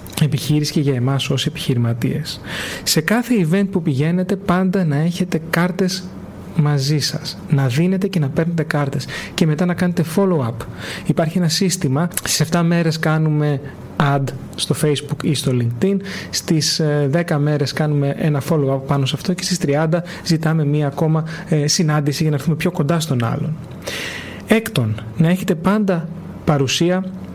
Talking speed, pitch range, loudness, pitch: 150 wpm, 145-175 Hz, -18 LUFS, 155 Hz